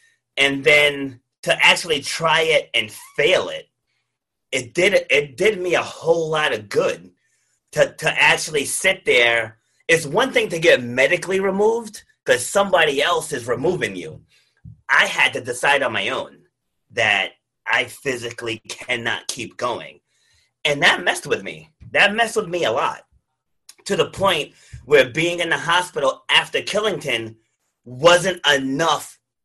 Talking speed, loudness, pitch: 150 wpm, -18 LUFS, 190 Hz